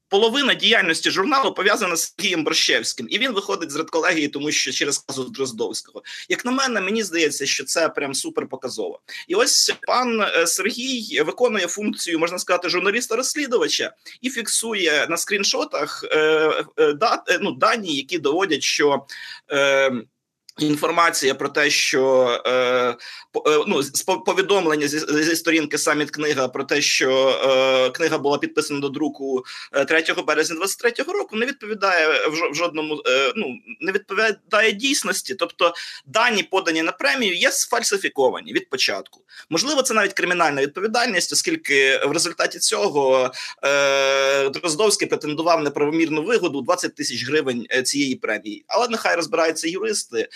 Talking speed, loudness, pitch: 140 wpm, -20 LUFS, 175 Hz